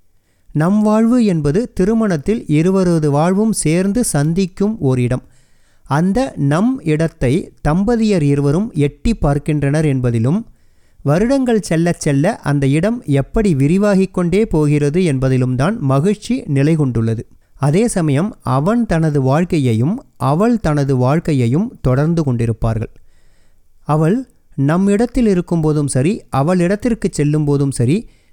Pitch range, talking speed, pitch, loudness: 140-200 Hz, 105 wpm, 155 Hz, -15 LUFS